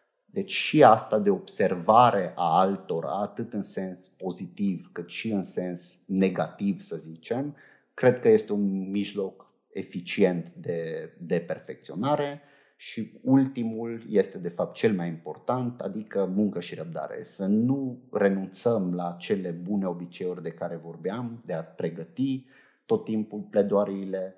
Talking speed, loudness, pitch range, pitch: 135 wpm, -27 LUFS, 90-115 Hz, 100 Hz